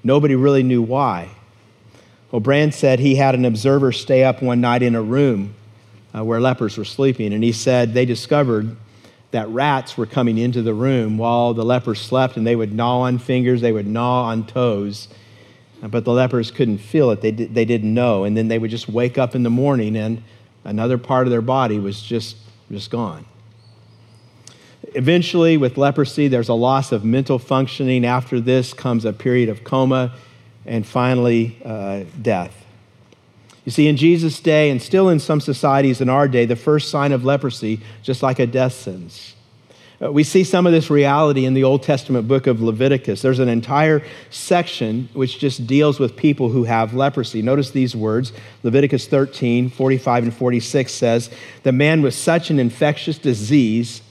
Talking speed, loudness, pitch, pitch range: 180 wpm, -18 LUFS, 125 Hz, 115-135 Hz